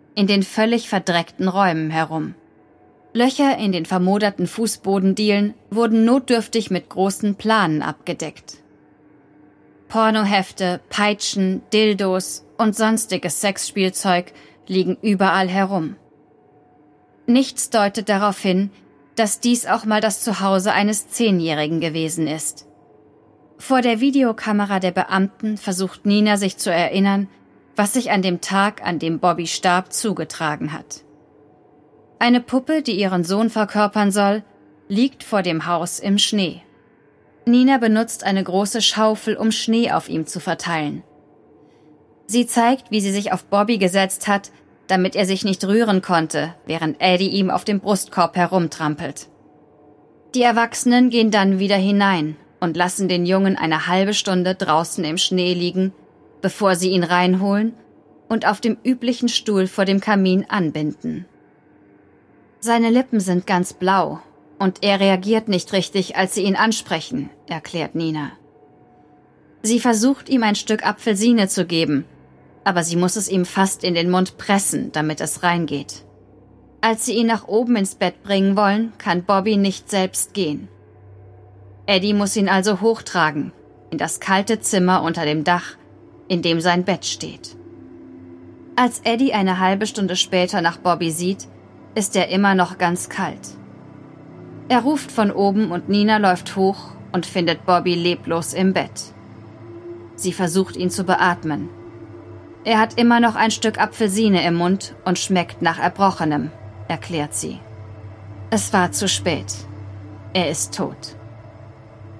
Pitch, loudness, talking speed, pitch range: 190 Hz, -19 LUFS, 140 wpm, 160-210 Hz